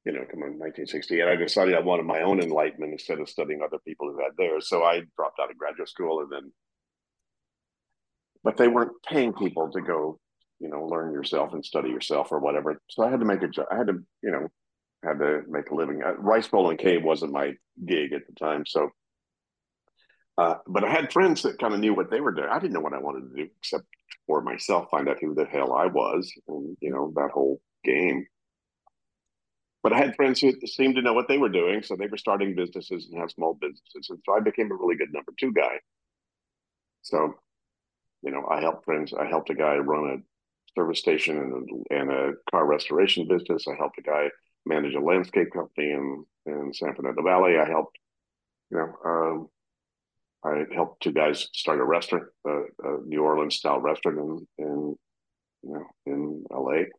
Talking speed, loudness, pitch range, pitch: 210 wpm, -26 LUFS, 75-120 Hz, 75 Hz